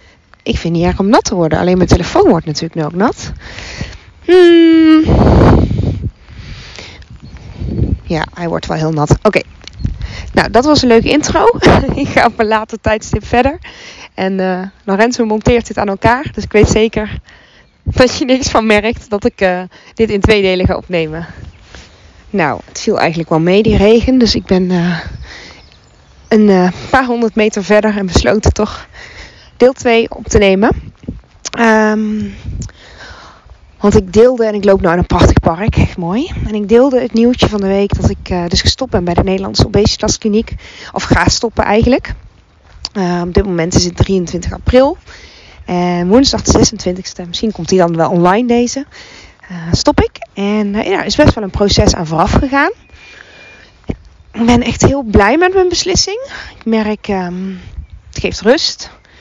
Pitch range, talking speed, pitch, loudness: 180-240 Hz, 175 wpm, 215 Hz, -12 LUFS